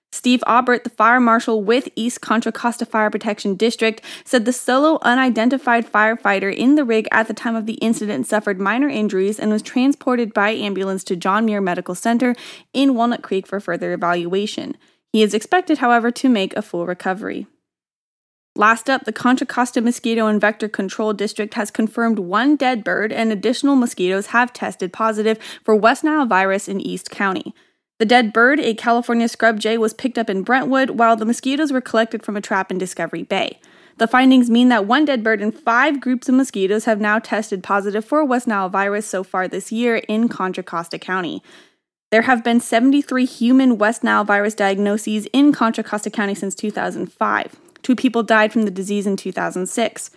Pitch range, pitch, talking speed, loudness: 205-245 Hz, 225 Hz, 185 wpm, -18 LUFS